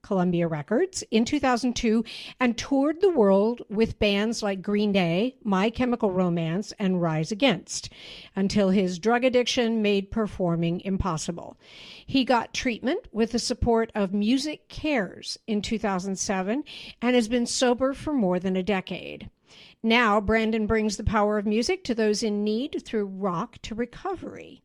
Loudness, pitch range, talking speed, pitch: -25 LUFS, 195-245 Hz, 150 wpm, 220 Hz